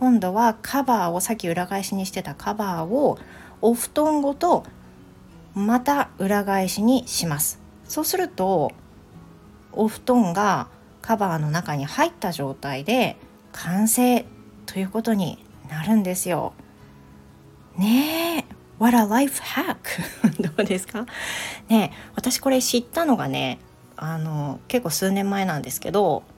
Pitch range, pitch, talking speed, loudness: 160-240 Hz, 200 Hz, 215 characters per minute, -23 LUFS